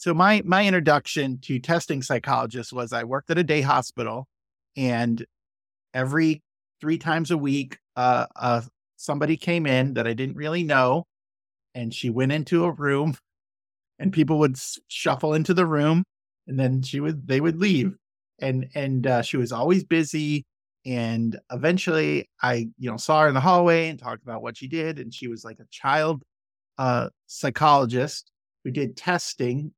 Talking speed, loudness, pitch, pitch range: 170 wpm, -24 LUFS, 135 Hz, 125-160 Hz